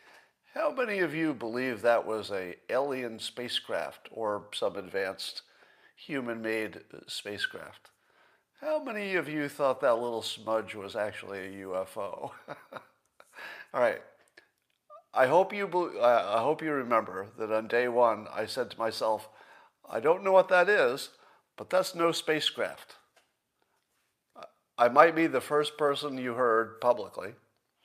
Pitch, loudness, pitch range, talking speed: 130 Hz, -29 LUFS, 110-170 Hz, 140 wpm